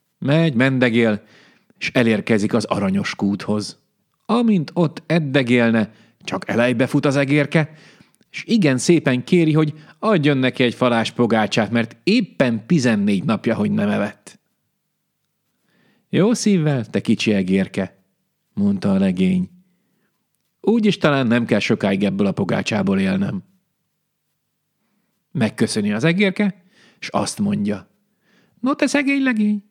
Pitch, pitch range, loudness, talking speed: 165 Hz, 125-200 Hz, -19 LUFS, 120 wpm